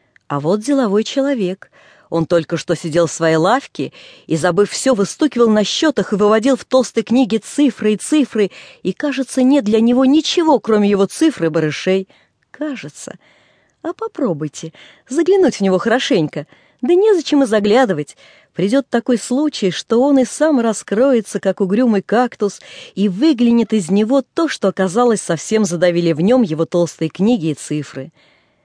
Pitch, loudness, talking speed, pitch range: 220 Hz, -16 LUFS, 155 wpm, 185-270 Hz